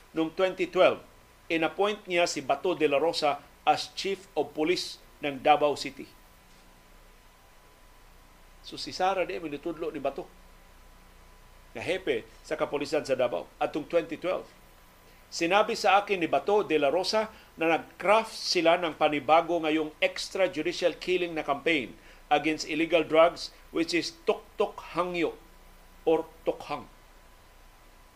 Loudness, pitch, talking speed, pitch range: -28 LUFS, 160 Hz, 120 wpm, 150-180 Hz